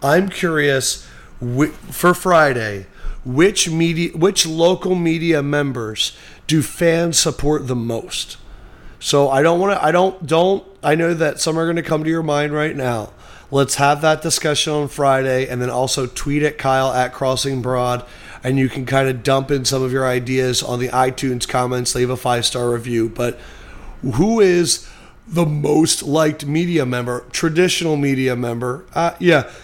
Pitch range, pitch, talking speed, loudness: 125-165 Hz, 140 Hz, 170 wpm, -17 LUFS